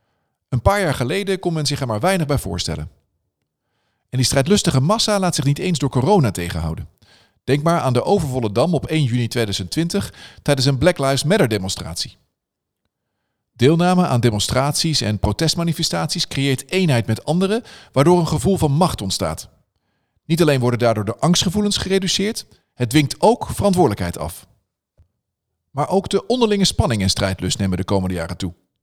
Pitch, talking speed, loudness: 135 Hz, 160 wpm, -18 LUFS